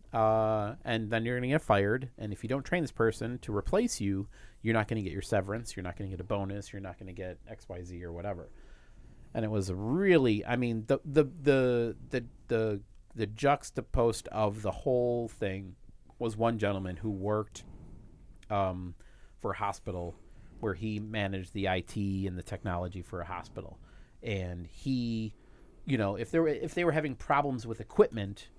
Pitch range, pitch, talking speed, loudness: 95-120 Hz, 105 Hz, 190 wpm, -32 LUFS